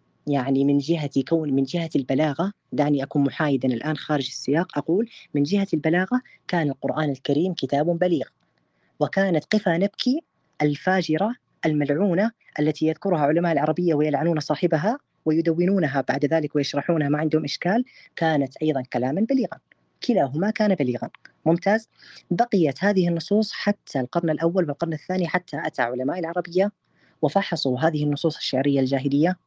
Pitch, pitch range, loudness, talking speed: 160 Hz, 145-185 Hz, -23 LUFS, 130 wpm